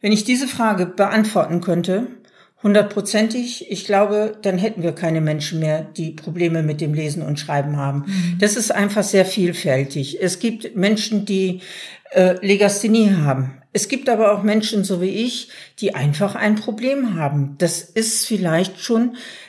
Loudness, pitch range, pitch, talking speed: -19 LUFS, 170-220 Hz, 200 Hz, 160 wpm